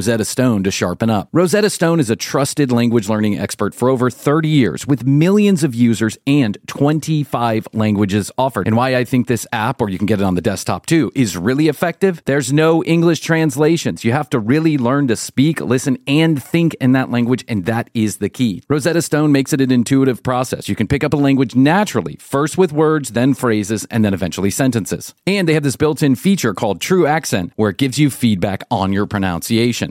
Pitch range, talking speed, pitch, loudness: 110-150 Hz, 210 wpm, 130 Hz, -16 LUFS